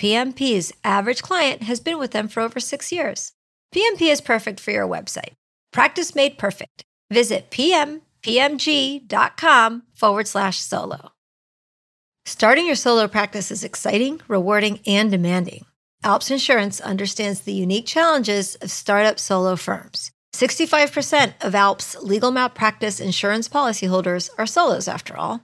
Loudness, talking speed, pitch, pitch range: -19 LUFS, 135 wpm, 220 Hz, 200-275 Hz